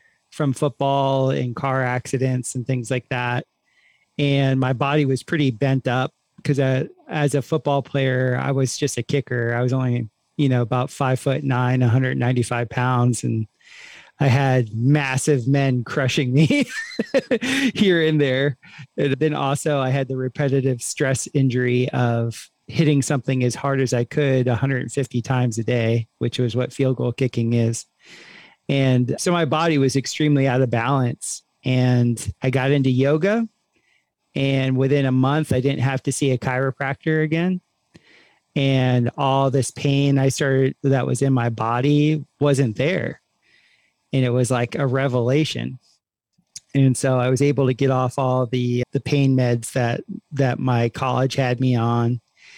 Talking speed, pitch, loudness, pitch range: 160 wpm, 135 Hz, -21 LUFS, 125-140 Hz